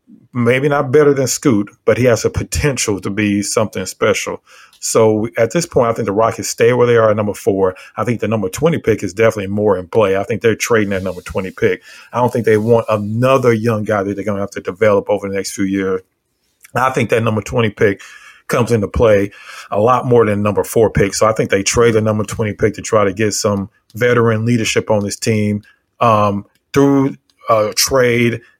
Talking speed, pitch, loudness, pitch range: 225 wpm, 110 Hz, -15 LUFS, 100-120 Hz